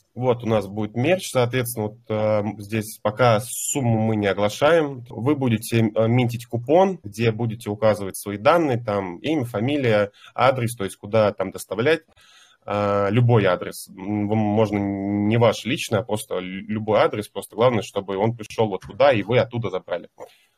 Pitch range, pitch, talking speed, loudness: 105-120 Hz, 110 Hz, 155 wpm, -22 LUFS